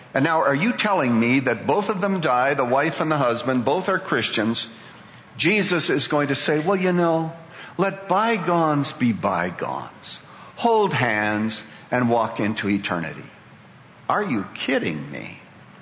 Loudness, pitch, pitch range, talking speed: -21 LUFS, 150 Hz, 115-185 Hz, 155 wpm